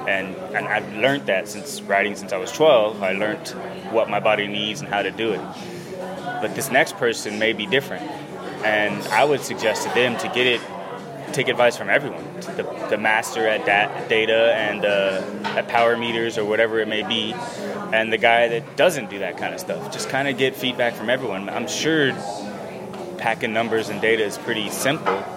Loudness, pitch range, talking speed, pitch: -21 LUFS, 105-115 Hz, 200 wpm, 110 Hz